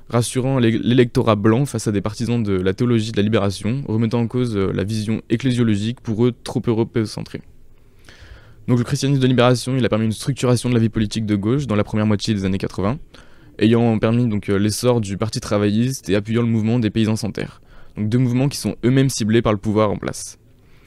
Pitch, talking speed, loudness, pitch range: 115 Hz, 215 wpm, -19 LUFS, 105-125 Hz